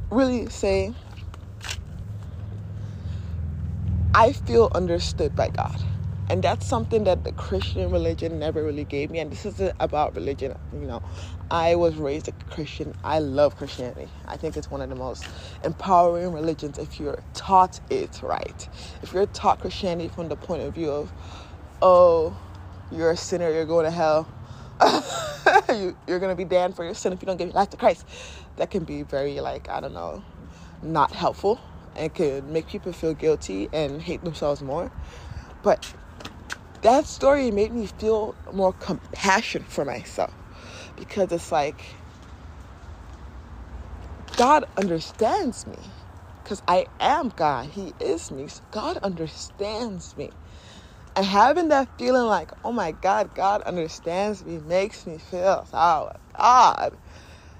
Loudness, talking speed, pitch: -24 LUFS, 150 wpm, 150 Hz